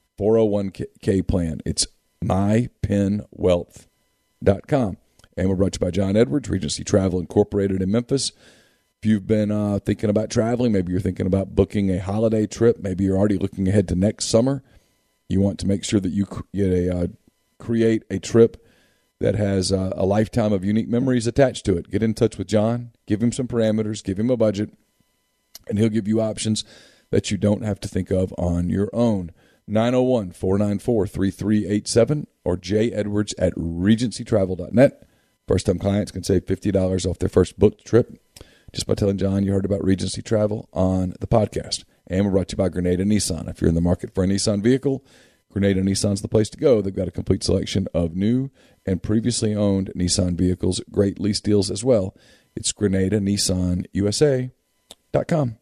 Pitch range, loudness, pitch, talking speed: 95-110 Hz, -22 LUFS, 100 Hz, 180 wpm